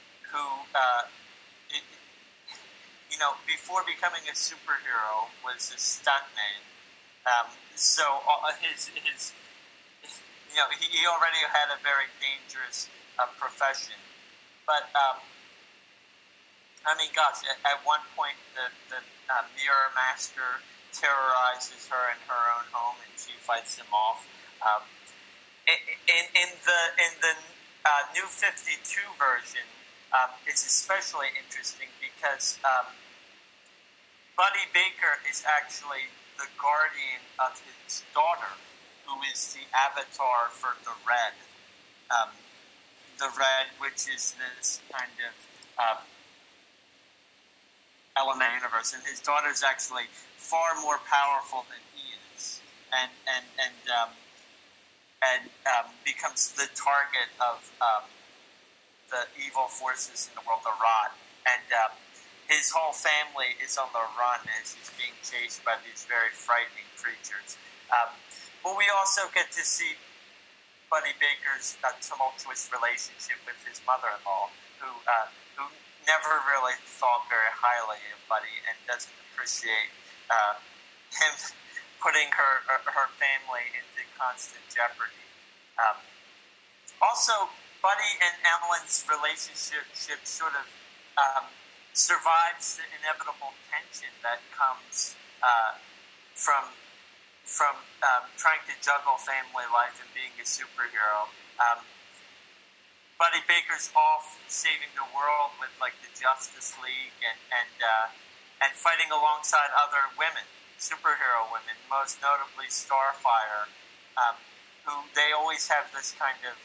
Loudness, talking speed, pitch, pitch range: -28 LUFS, 125 wpm, 140 Hz, 125-160 Hz